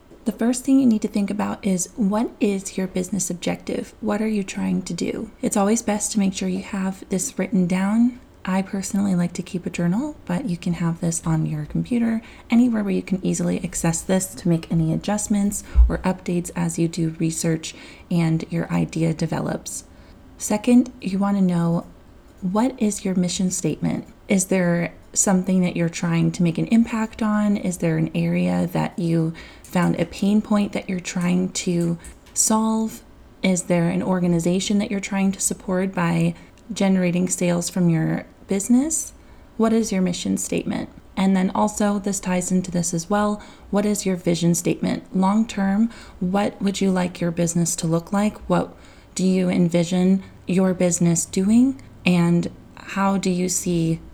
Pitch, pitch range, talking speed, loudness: 185 Hz, 175-205 Hz, 175 wpm, -22 LUFS